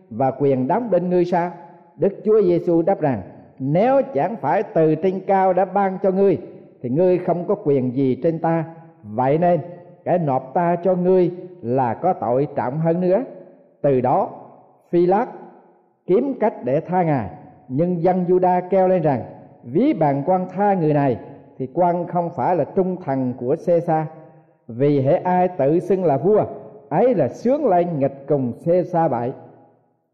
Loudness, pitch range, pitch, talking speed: -20 LUFS, 140-185 Hz, 170 Hz, 175 wpm